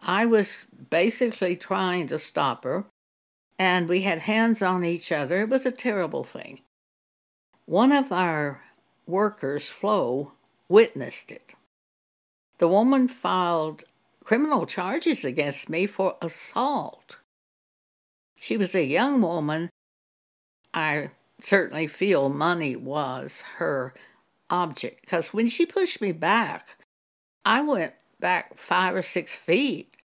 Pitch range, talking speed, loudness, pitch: 165-230 Hz, 120 wpm, -25 LUFS, 185 Hz